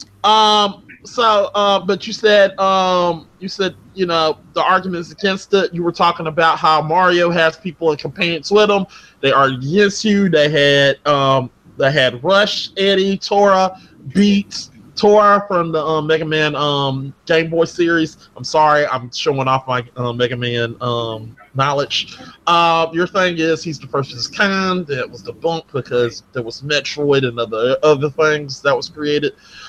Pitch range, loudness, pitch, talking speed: 140-190 Hz, -16 LUFS, 160 Hz, 175 wpm